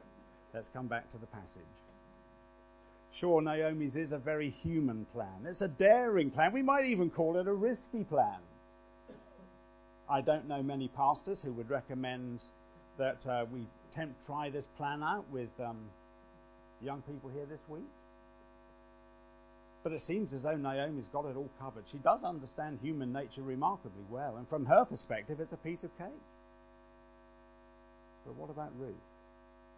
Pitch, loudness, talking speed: 155 Hz, -35 LUFS, 155 wpm